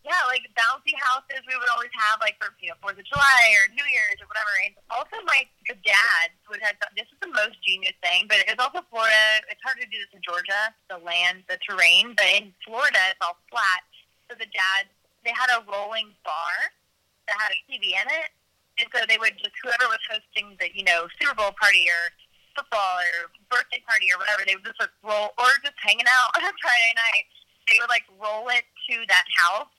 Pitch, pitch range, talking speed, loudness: 215 Hz, 195-250 Hz, 225 wpm, -21 LUFS